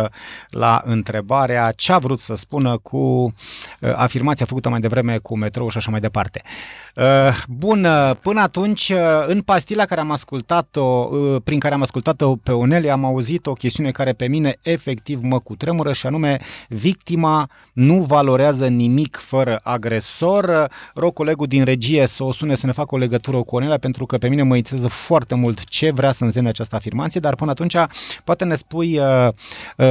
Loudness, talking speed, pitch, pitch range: -18 LUFS, 185 wpm, 135 Hz, 125-155 Hz